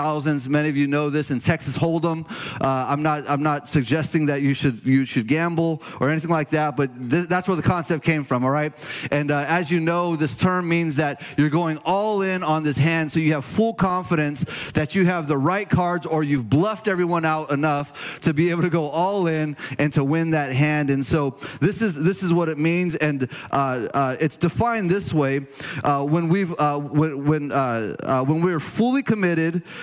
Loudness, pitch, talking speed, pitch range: -22 LUFS, 155 Hz, 215 wpm, 145-170 Hz